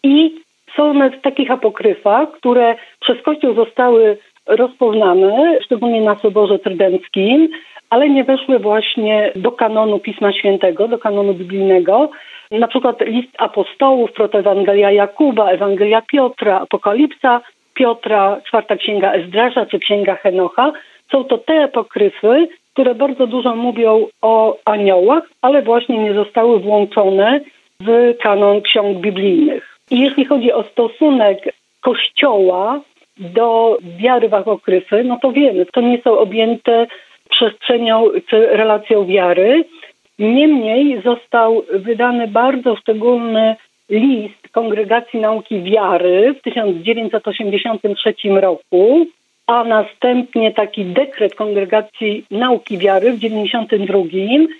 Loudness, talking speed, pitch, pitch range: -14 LUFS, 110 wpm, 225 Hz, 205-255 Hz